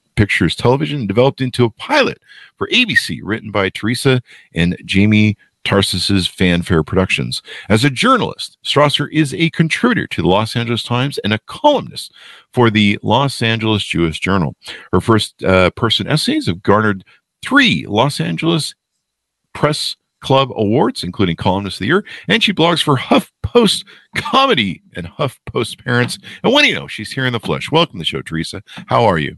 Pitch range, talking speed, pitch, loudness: 100-145 Hz, 165 wpm, 115 Hz, -15 LUFS